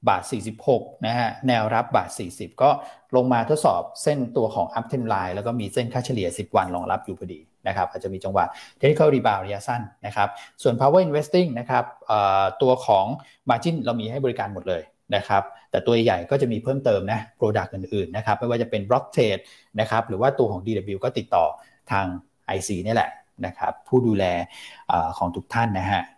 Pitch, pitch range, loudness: 115 Hz, 100-125 Hz, -23 LUFS